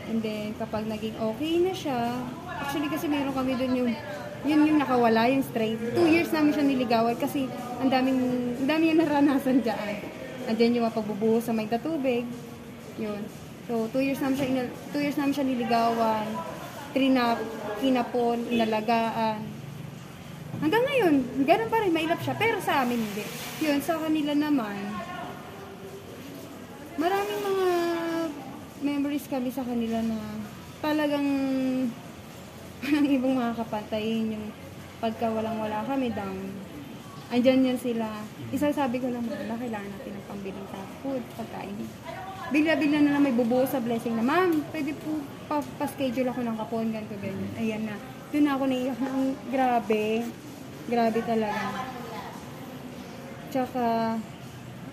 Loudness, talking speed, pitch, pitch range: -27 LUFS, 140 wpm, 255 Hz, 225-285 Hz